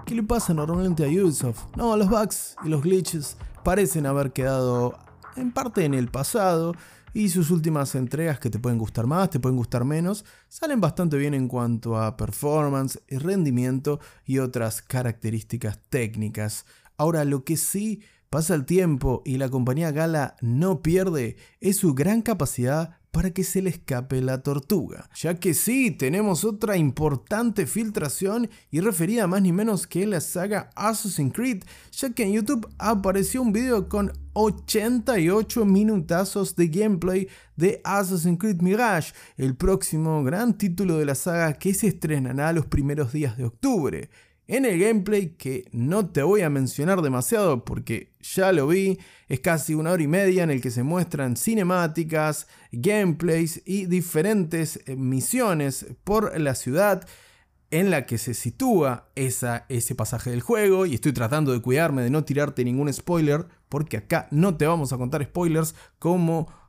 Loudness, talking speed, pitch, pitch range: -24 LUFS, 160 wpm, 165 Hz, 135-195 Hz